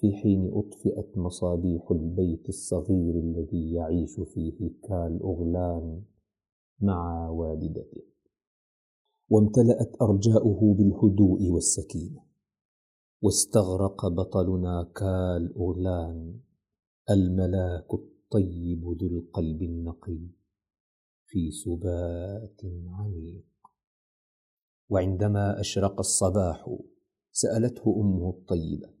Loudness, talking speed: -27 LUFS, 70 wpm